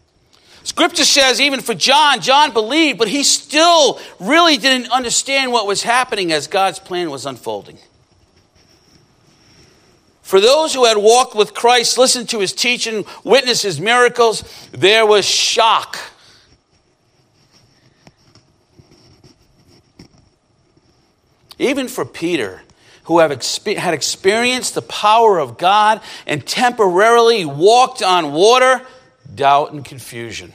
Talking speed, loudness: 110 wpm, -13 LUFS